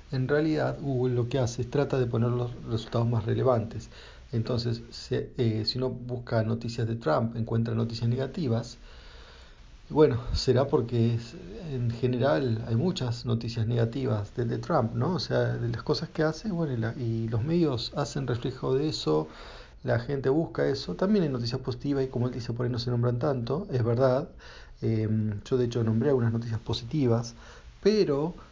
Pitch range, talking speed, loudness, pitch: 115-135 Hz, 180 wpm, -28 LUFS, 120 Hz